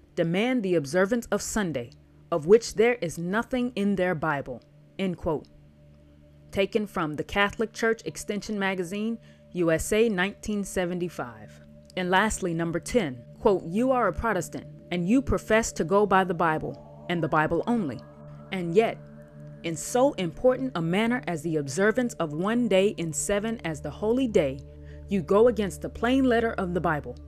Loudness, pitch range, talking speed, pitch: -26 LUFS, 150-220 Hz, 160 wpm, 180 Hz